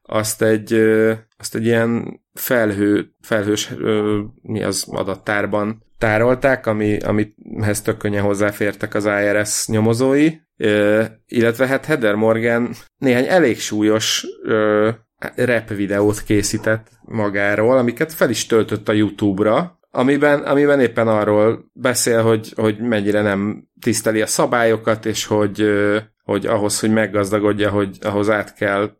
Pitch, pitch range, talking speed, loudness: 110 Hz, 105-115 Hz, 130 wpm, -18 LUFS